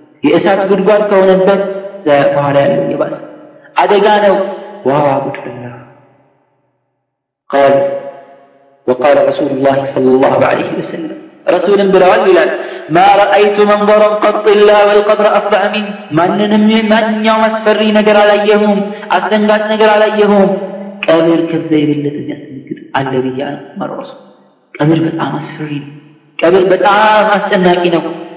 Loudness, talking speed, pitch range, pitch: -10 LUFS, 115 wpm, 145-210 Hz, 195 Hz